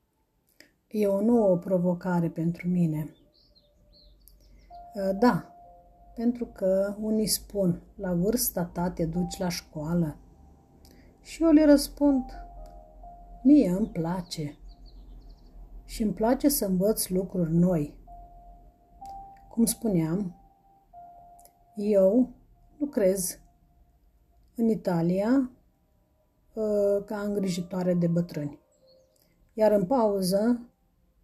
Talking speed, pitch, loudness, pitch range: 85 wpm, 195 Hz, -26 LUFS, 175-235 Hz